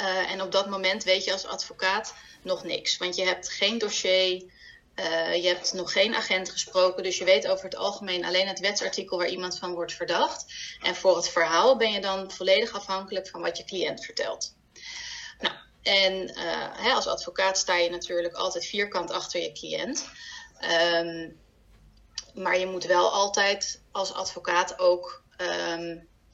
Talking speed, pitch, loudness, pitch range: 170 wpm, 185 Hz, -26 LUFS, 180-195 Hz